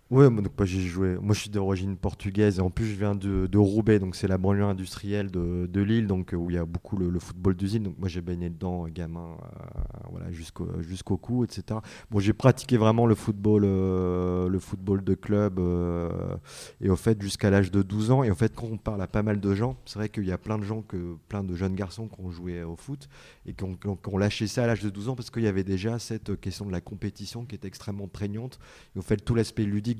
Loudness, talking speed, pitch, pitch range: -27 LUFS, 260 wpm, 100 Hz, 95-110 Hz